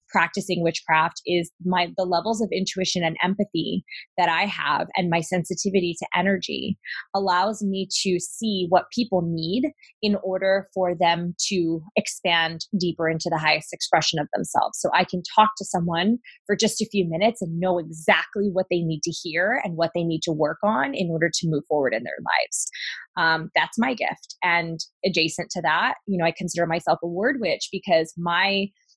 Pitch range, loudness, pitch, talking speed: 165-195 Hz, -23 LUFS, 180 Hz, 185 wpm